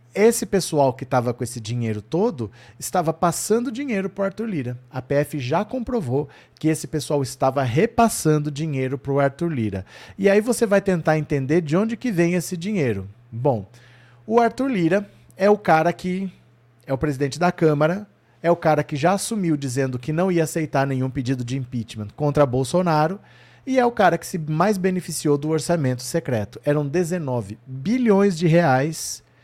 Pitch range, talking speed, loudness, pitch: 135-185 Hz, 175 wpm, -22 LUFS, 155 Hz